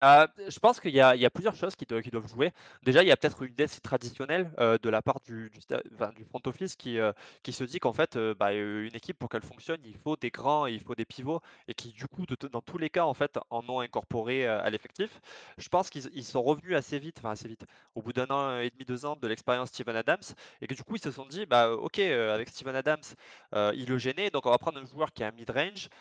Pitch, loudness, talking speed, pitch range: 130 Hz, -30 LUFS, 290 wpm, 115-150 Hz